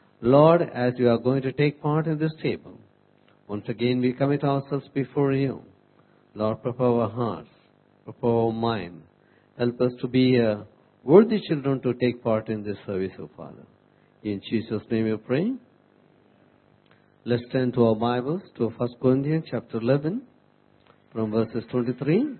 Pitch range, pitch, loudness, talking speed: 110-140 Hz, 125 Hz, -24 LUFS, 160 wpm